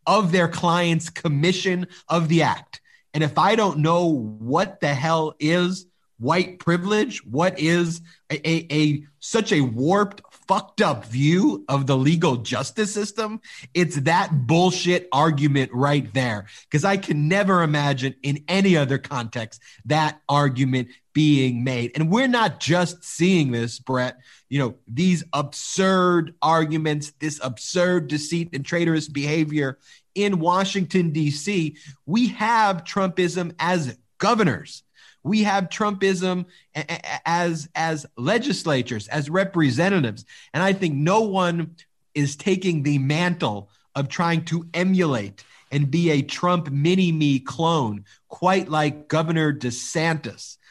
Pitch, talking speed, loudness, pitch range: 160 Hz, 130 wpm, -22 LUFS, 140-180 Hz